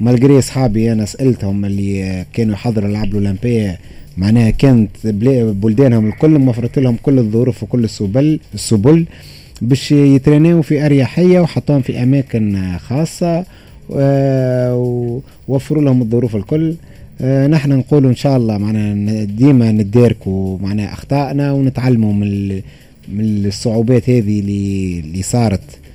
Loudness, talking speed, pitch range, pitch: -14 LUFS, 110 wpm, 105-135 Hz, 120 Hz